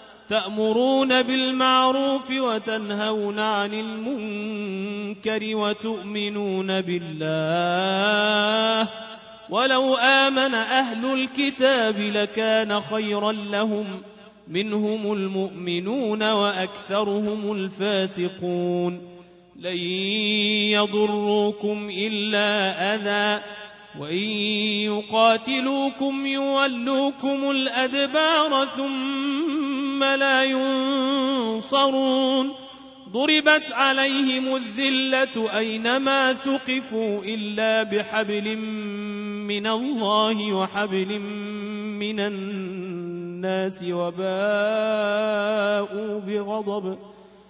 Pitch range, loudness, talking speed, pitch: 205-260 Hz, -23 LUFS, 55 wpm, 215 Hz